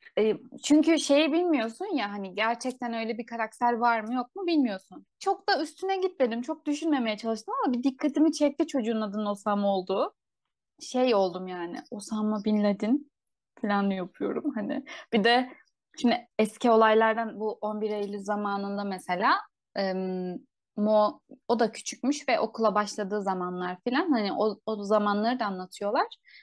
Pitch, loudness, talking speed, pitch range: 230 Hz, -28 LUFS, 145 wpm, 210-285 Hz